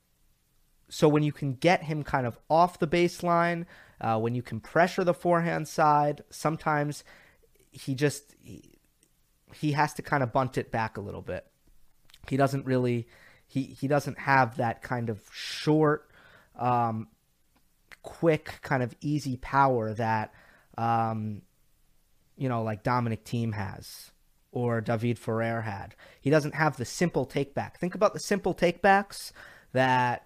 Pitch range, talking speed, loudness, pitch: 115-155 Hz, 150 wpm, -28 LUFS, 135 Hz